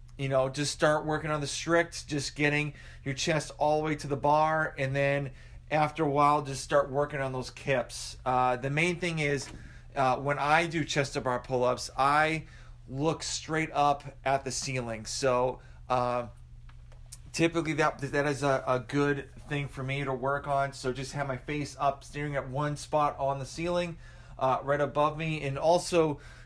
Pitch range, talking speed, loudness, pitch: 130-150 Hz, 190 wpm, -29 LUFS, 140 Hz